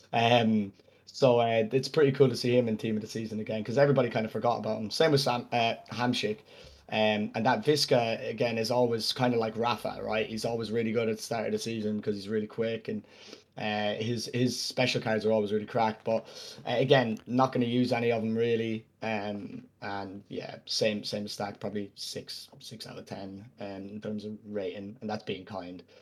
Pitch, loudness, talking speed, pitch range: 110 Hz, -29 LUFS, 215 wpm, 105-120 Hz